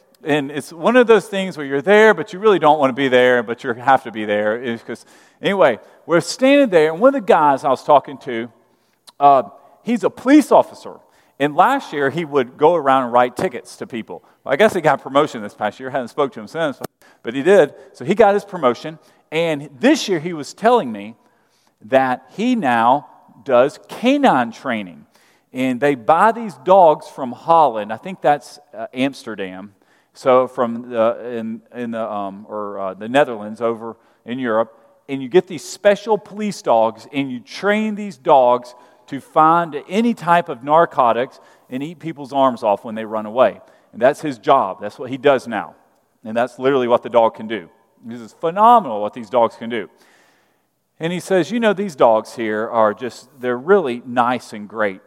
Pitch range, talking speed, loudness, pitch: 115-185 Hz, 200 wpm, -17 LUFS, 140 Hz